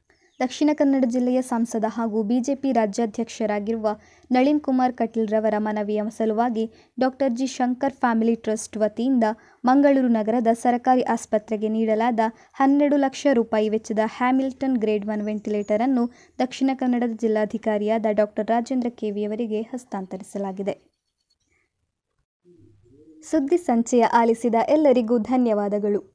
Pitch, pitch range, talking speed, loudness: 230 Hz, 215-255 Hz, 105 wpm, -22 LUFS